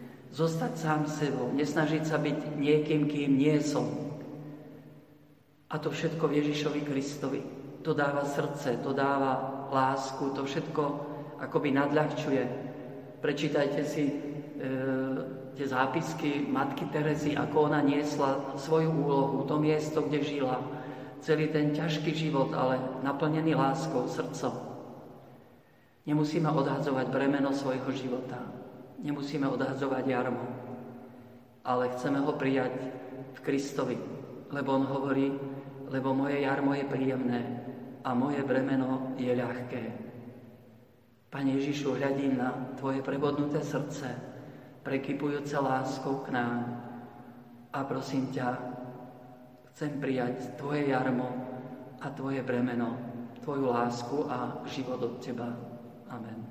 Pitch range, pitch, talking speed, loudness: 125-145 Hz, 135 Hz, 110 wpm, -31 LUFS